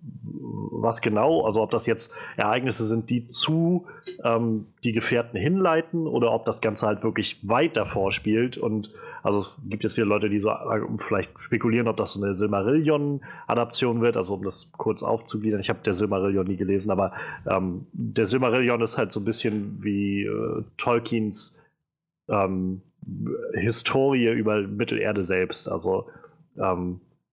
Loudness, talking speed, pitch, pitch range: -25 LUFS, 155 wpm, 110 Hz, 100-120 Hz